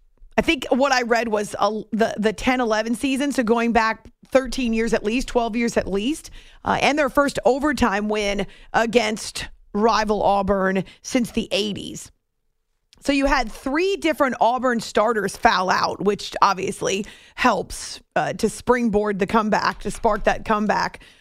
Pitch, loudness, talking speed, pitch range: 225 Hz, -21 LUFS, 160 wpm, 210-255 Hz